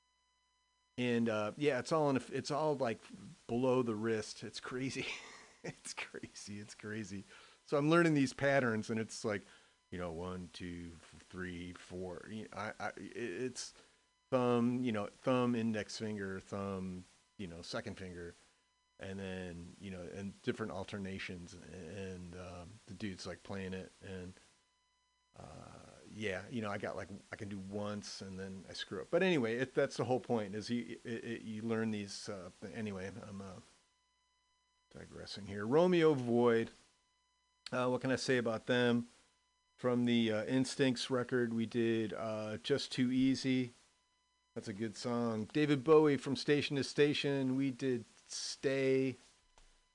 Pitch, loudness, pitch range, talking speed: 120 Hz, -37 LUFS, 100-135 Hz, 160 wpm